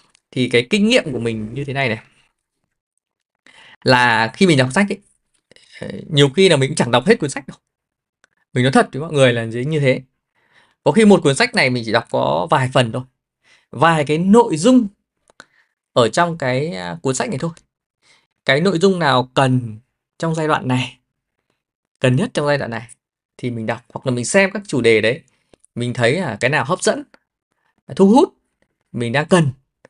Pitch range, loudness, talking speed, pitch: 125-185 Hz, -17 LUFS, 200 wpm, 140 Hz